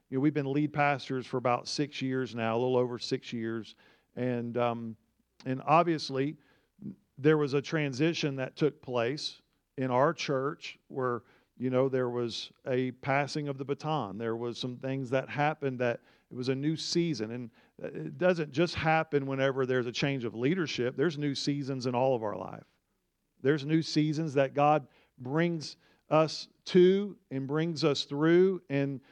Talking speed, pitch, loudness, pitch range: 175 wpm, 140 Hz, -30 LUFS, 125-155 Hz